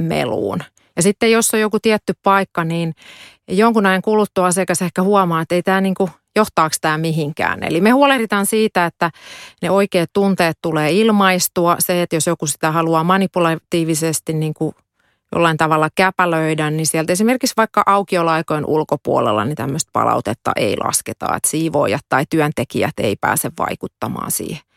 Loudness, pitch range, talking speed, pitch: -17 LUFS, 160-200 Hz, 155 wpm, 175 Hz